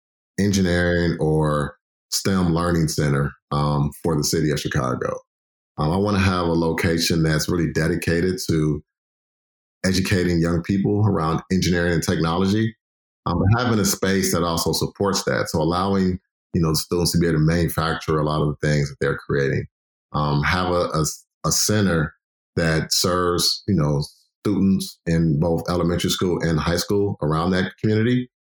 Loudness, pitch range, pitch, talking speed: -21 LUFS, 80-95 Hz, 85 Hz, 160 wpm